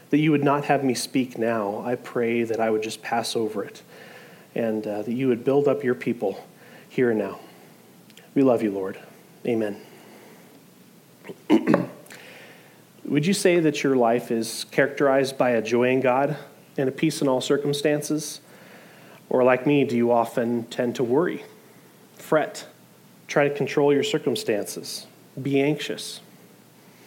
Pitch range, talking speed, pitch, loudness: 115-145 Hz, 155 wpm, 130 Hz, -24 LUFS